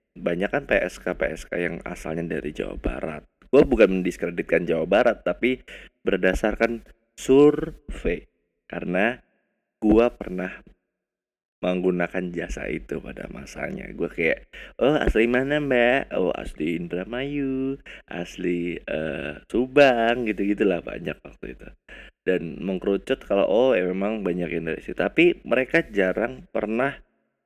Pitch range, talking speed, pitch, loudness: 90-130 Hz, 115 wpm, 110 Hz, -24 LUFS